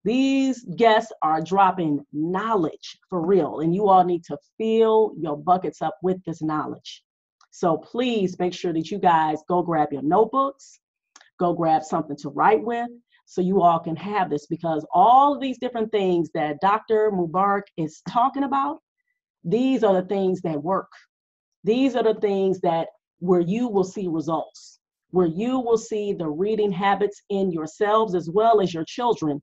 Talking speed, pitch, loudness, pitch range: 170 wpm, 190 Hz, -22 LUFS, 165-220 Hz